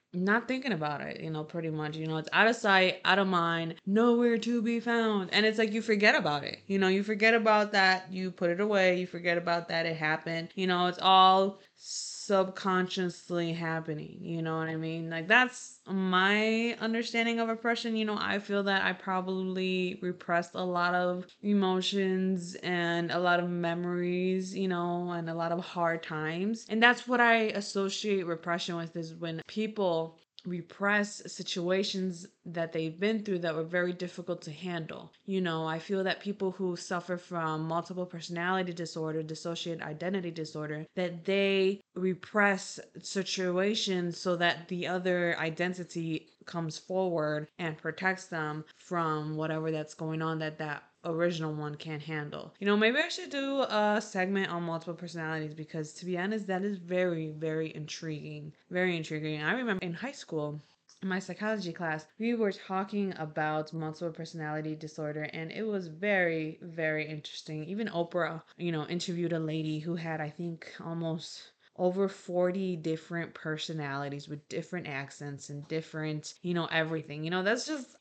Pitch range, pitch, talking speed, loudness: 160-195 Hz, 175 Hz, 170 wpm, -31 LUFS